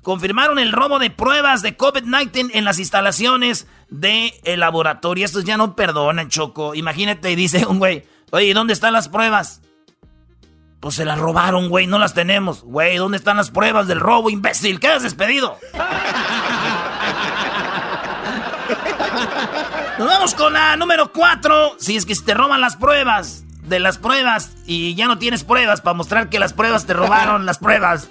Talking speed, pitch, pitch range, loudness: 165 wpm, 205 Hz, 175-230 Hz, -16 LUFS